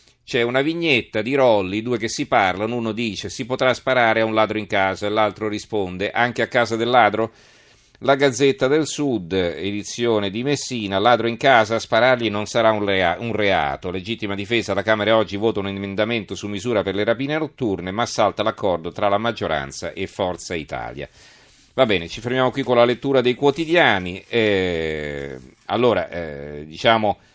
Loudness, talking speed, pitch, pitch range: -20 LUFS, 175 wpm, 110 Hz, 100-125 Hz